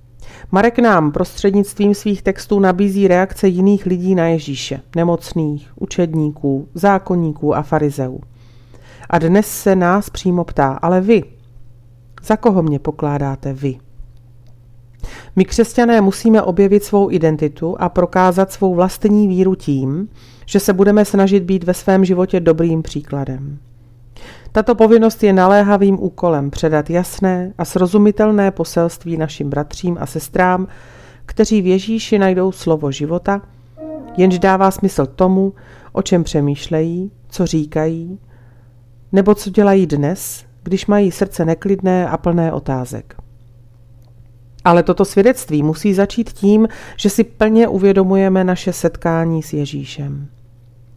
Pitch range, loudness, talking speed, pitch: 140-195 Hz, -15 LUFS, 125 wpm, 175 Hz